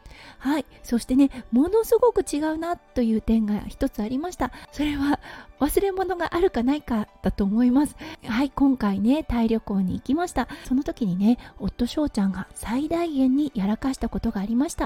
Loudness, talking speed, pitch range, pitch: -24 LUFS, 355 characters per minute, 225-300 Hz, 265 Hz